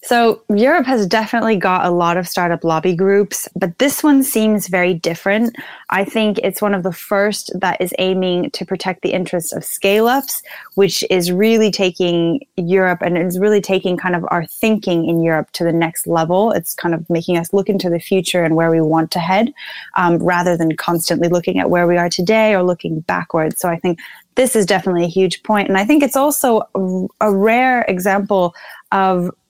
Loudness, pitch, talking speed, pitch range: -16 LUFS, 185 Hz, 200 wpm, 175-210 Hz